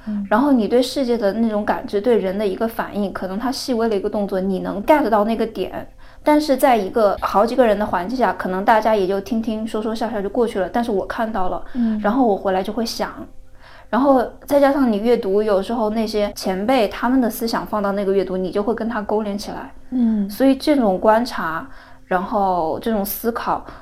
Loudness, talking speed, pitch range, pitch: -19 LUFS, 325 characters per minute, 200-235 Hz, 215 Hz